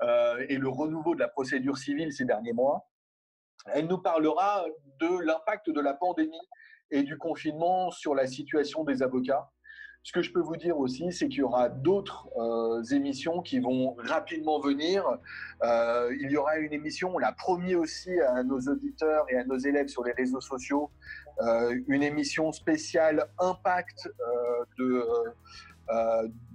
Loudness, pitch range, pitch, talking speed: -29 LUFS, 130-175 Hz, 150 Hz, 170 wpm